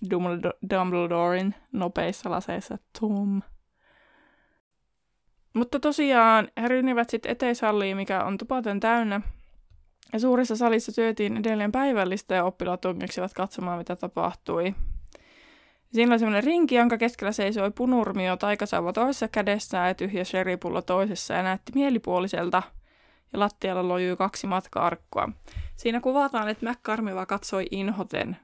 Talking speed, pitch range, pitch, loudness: 115 wpm, 185-235 Hz, 205 Hz, -26 LUFS